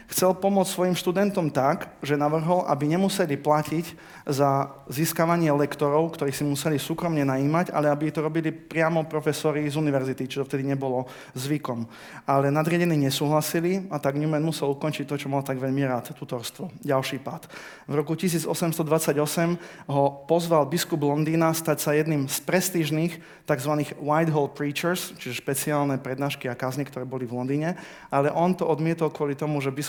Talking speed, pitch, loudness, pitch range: 160 wpm, 150 Hz, -25 LUFS, 140-165 Hz